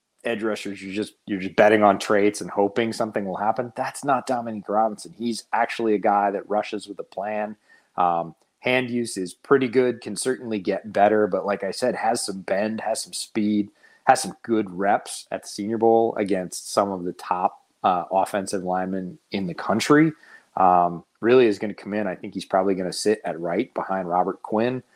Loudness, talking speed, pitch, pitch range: -23 LUFS, 205 wpm, 105 Hz, 95-110 Hz